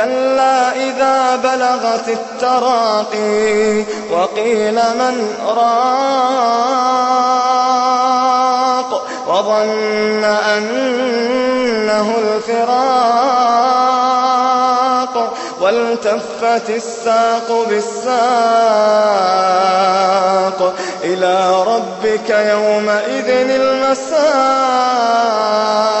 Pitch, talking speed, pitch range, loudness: 235 Hz, 40 wpm, 215-255 Hz, -14 LUFS